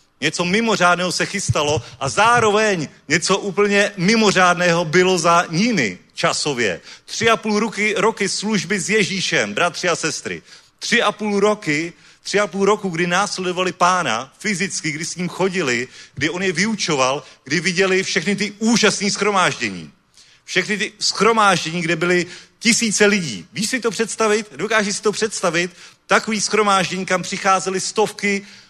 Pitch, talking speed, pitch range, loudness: 190 Hz, 145 wpm, 175-210 Hz, -18 LUFS